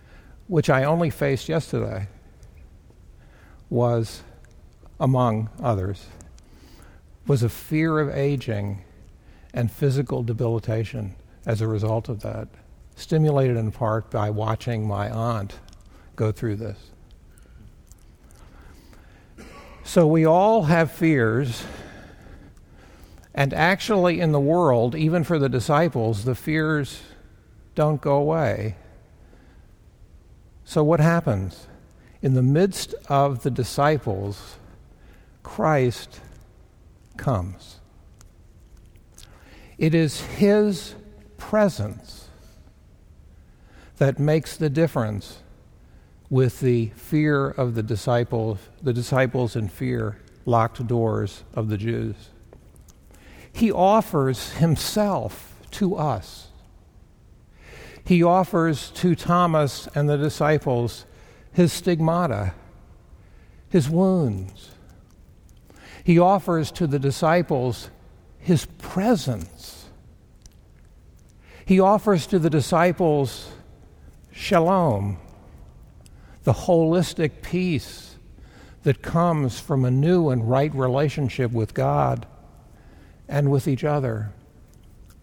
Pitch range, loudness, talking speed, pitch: 95-150 Hz, -22 LUFS, 90 wpm, 115 Hz